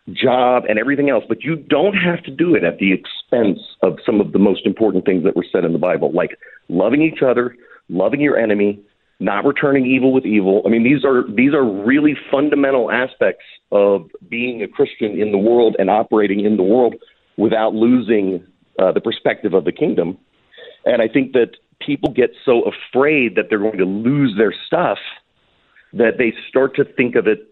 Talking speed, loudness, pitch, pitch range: 195 wpm, -16 LUFS, 125 Hz, 105-140 Hz